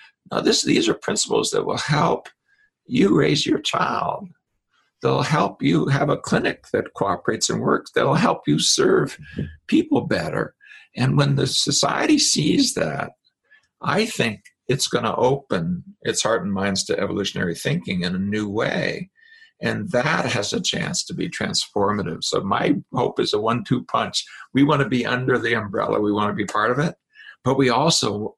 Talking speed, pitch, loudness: 180 wpm, 150 Hz, -21 LUFS